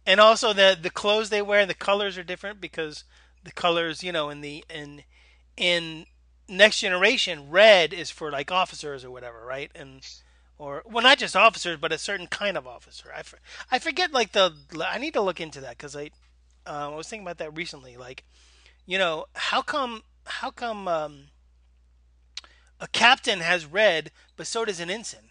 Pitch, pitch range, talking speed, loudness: 165 Hz, 135-200 Hz, 190 wpm, -23 LUFS